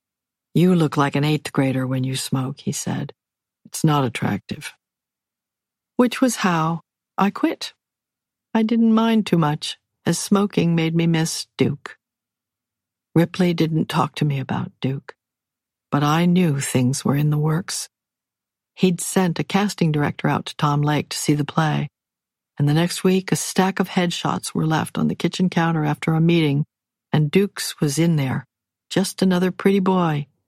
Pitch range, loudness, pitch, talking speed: 145-185 Hz, -21 LUFS, 160 Hz, 165 wpm